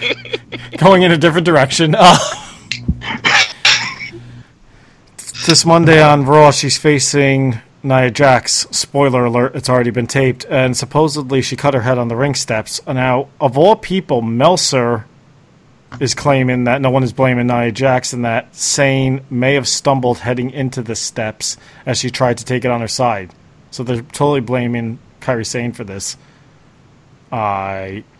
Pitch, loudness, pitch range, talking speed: 130 Hz, -13 LUFS, 120-140 Hz, 155 wpm